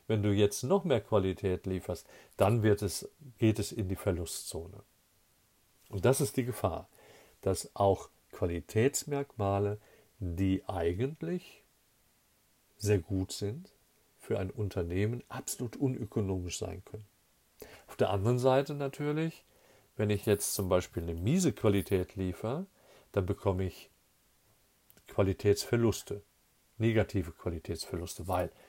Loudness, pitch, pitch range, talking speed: -33 LUFS, 100 Hz, 95-115 Hz, 115 wpm